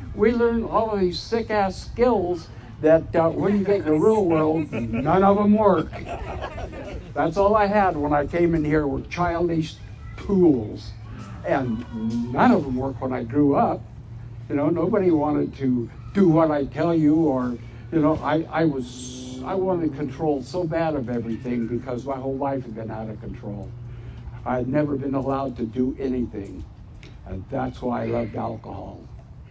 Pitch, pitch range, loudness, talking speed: 135 Hz, 120-165 Hz, -23 LUFS, 180 wpm